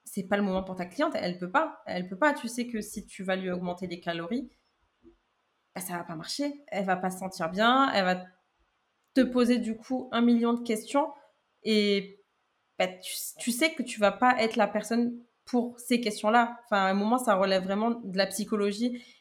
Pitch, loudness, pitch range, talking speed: 220 Hz, -28 LUFS, 195-245 Hz, 215 wpm